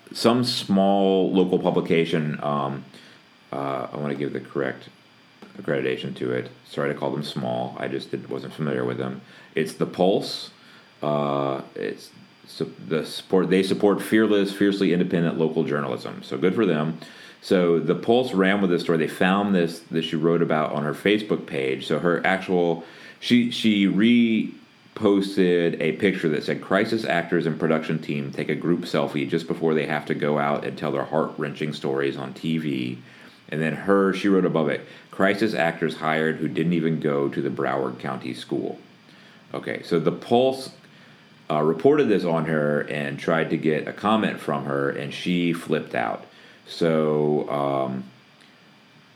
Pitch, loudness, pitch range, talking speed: 80 Hz, -23 LUFS, 70-90 Hz, 170 wpm